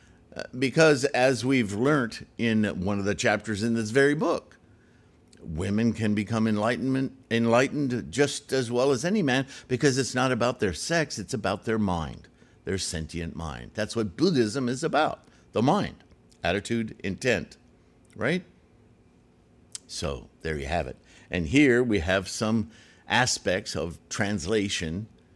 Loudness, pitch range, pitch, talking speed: -26 LUFS, 95-125 Hz, 115 Hz, 140 wpm